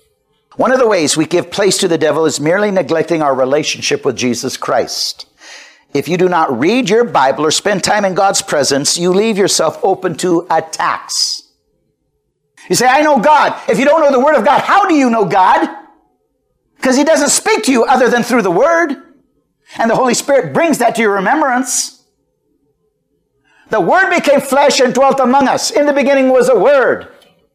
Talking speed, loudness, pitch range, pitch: 195 wpm, -12 LUFS, 180-280 Hz, 240 Hz